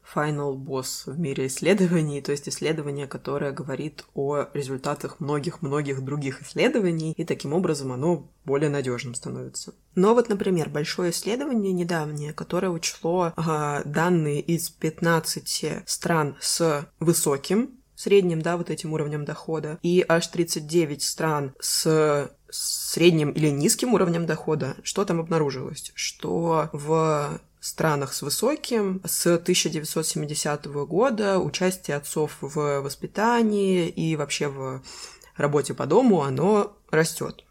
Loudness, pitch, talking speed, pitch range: -25 LUFS, 160 Hz, 125 wpm, 145-175 Hz